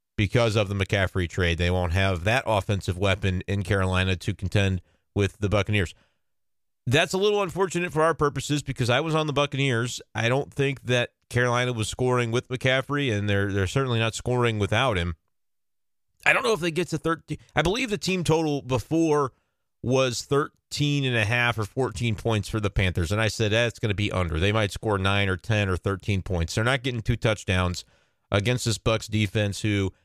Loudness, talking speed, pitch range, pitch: -25 LUFS, 200 wpm, 100-135 Hz, 110 Hz